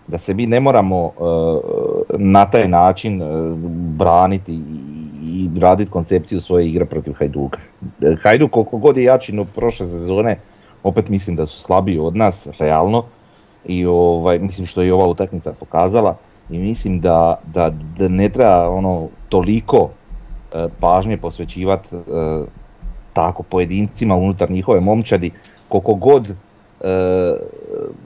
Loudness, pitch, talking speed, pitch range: -16 LUFS, 95 Hz, 140 wpm, 85-105 Hz